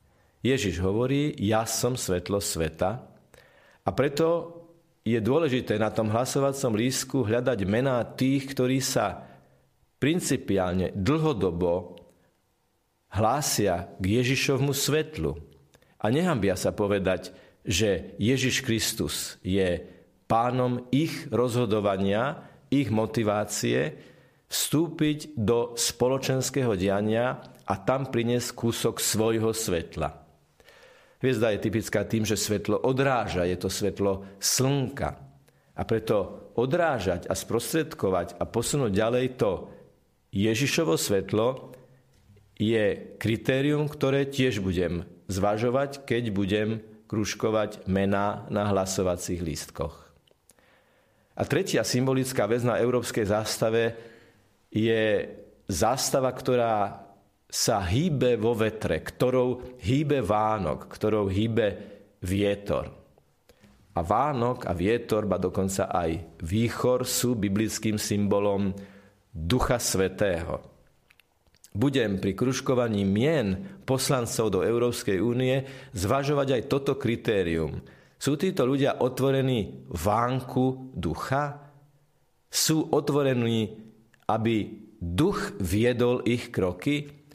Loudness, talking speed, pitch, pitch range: -27 LUFS, 95 wpm, 115 Hz, 100-130 Hz